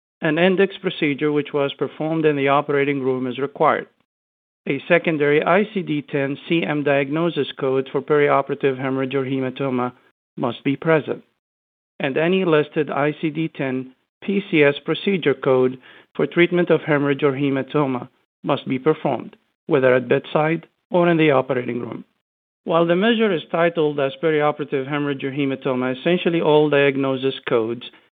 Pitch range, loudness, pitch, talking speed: 135-160 Hz, -20 LUFS, 145 Hz, 140 wpm